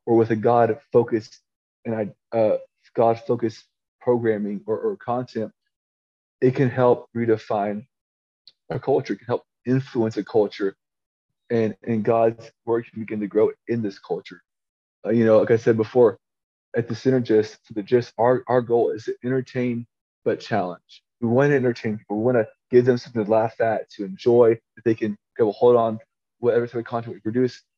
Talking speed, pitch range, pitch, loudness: 180 wpm, 110-125 Hz, 115 Hz, -22 LUFS